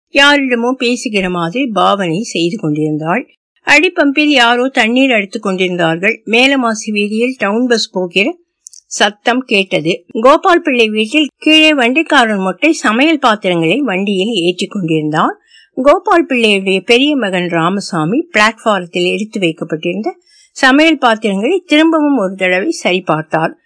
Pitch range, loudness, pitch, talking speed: 185-280 Hz, -12 LUFS, 230 Hz, 110 wpm